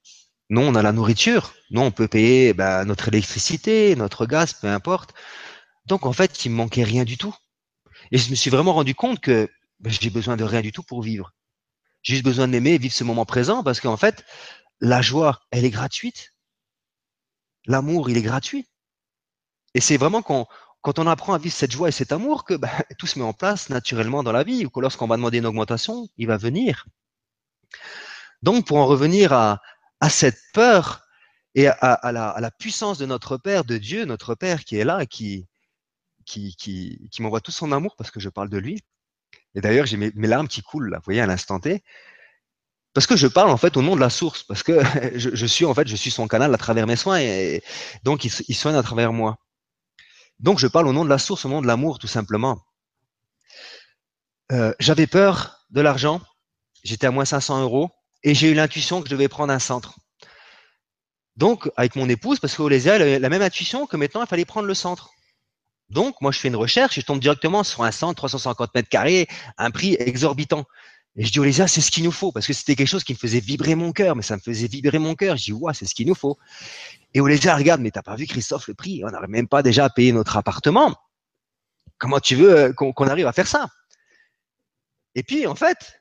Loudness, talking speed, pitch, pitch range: -20 LUFS, 225 wpm, 135 Hz, 115-165 Hz